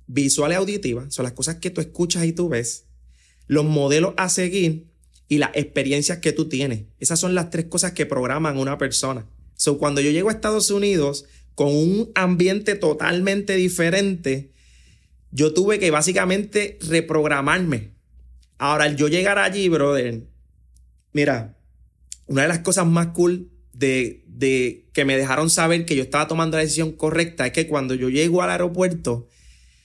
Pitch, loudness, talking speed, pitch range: 150 Hz, -20 LUFS, 165 wpm, 130-175 Hz